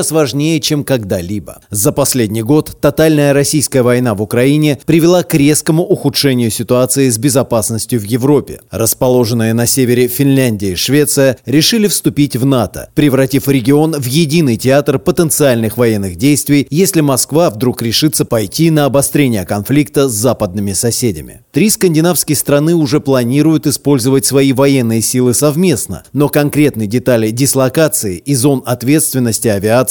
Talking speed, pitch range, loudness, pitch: 135 wpm, 120-150 Hz, -11 LUFS, 135 Hz